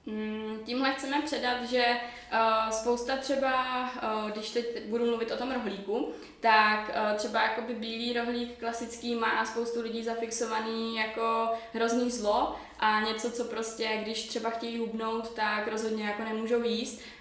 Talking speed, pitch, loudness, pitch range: 135 wpm, 230 Hz, -30 LUFS, 220-240 Hz